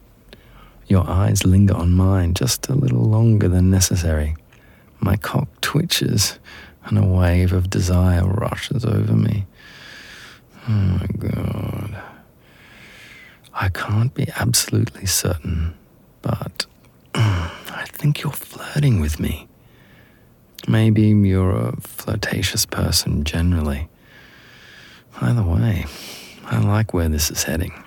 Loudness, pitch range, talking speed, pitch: -19 LUFS, 90-110 Hz, 110 wpm, 100 Hz